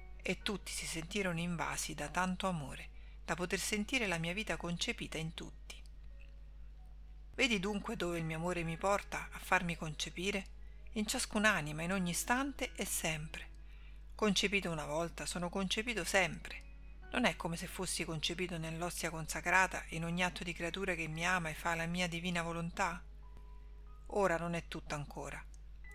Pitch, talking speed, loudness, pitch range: 170 Hz, 155 wpm, -37 LUFS, 160-195 Hz